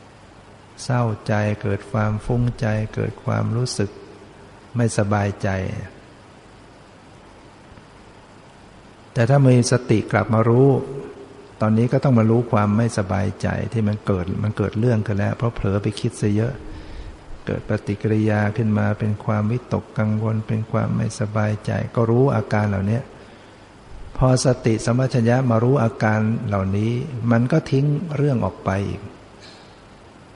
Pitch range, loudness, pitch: 105-120 Hz, -21 LUFS, 110 Hz